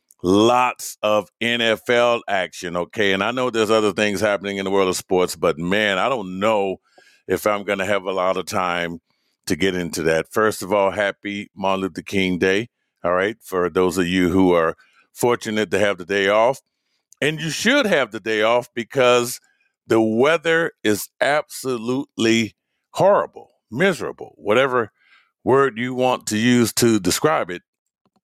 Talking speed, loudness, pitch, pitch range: 170 wpm, -20 LUFS, 105 Hz, 95-120 Hz